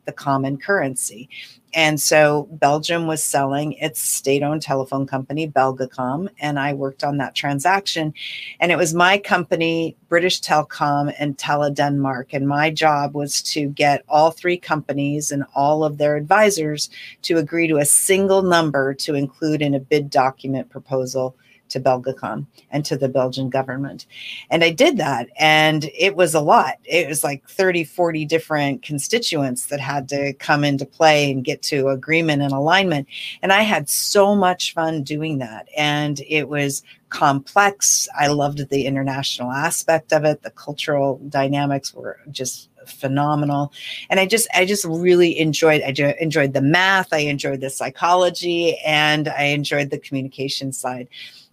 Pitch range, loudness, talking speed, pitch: 140-160 Hz, -19 LUFS, 160 wpm, 145 Hz